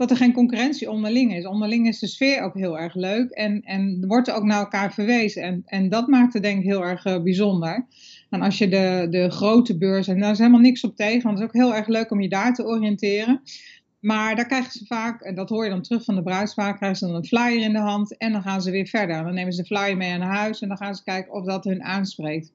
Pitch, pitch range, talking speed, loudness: 205 Hz, 190-230 Hz, 275 wpm, -22 LUFS